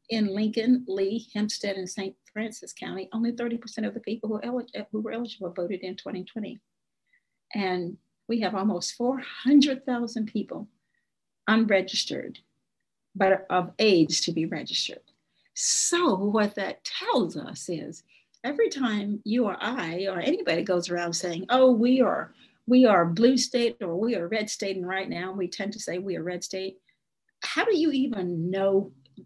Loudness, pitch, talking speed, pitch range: -26 LUFS, 210 Hz, 155 wpm, 190-240 Hz